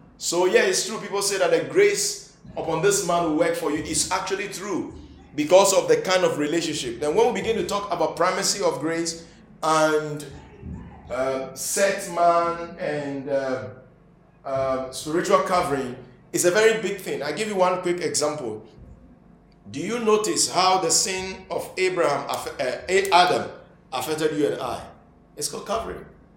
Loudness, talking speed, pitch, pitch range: -23 LUFS, 165 wpm, 170 Hz, 155-200 Hz